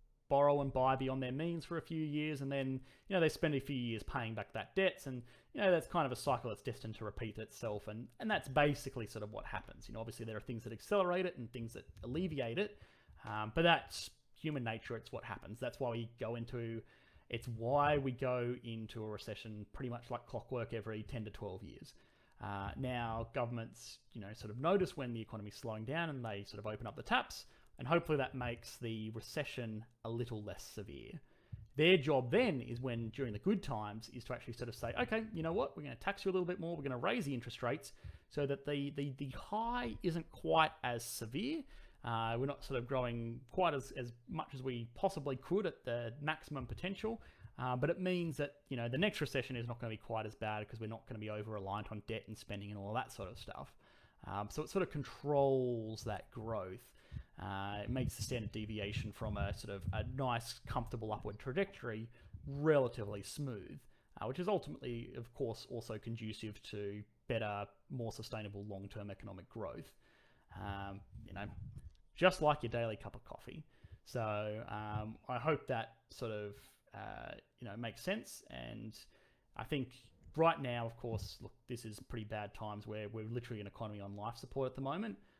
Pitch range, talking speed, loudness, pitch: 110-140 Hz, 215 wpm, -40 LUFS, 120 Hz